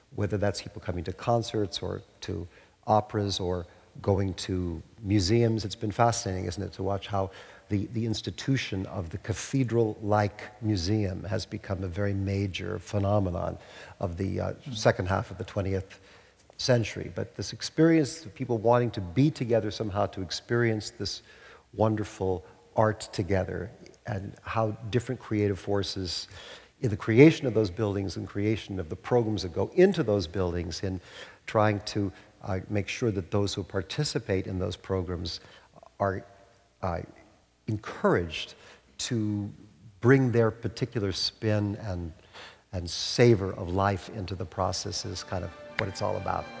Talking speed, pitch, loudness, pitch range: 150 wpm, 100 Hz, -29 LUFS, 95-110 Hz